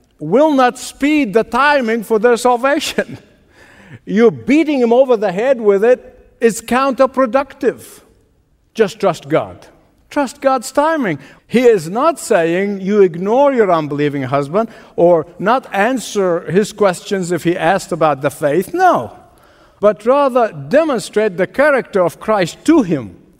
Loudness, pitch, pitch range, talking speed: -14 LUFS, 220 Hz, 180-265 Hz, 140 wpm